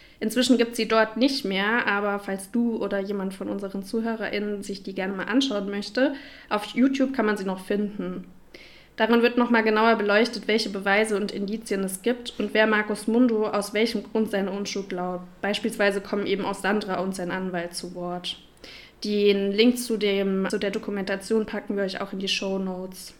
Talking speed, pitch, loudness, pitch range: 190 wpm, 205 Hz, -25 LUFS, 195-225 Hz